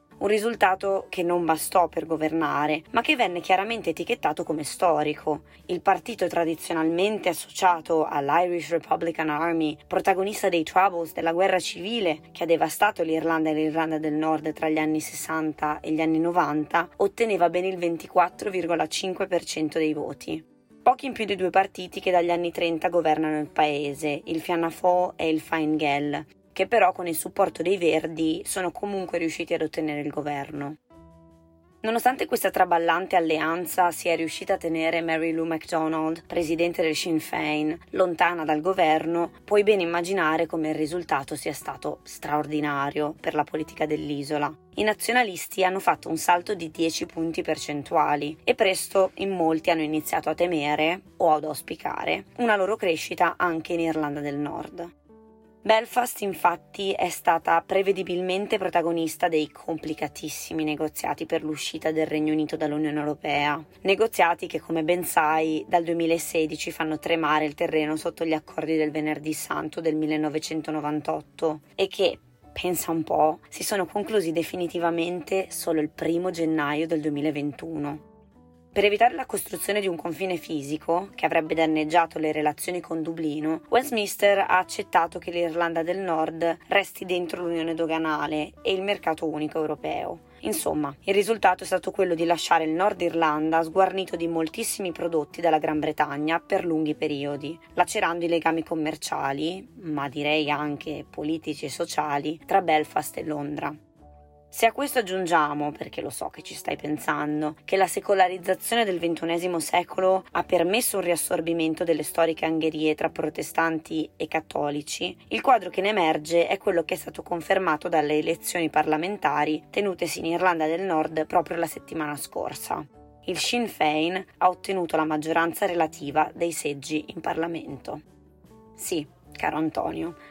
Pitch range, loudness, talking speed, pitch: 155-180 Hz, -25 LUFS, 150 wpm, 165 Hz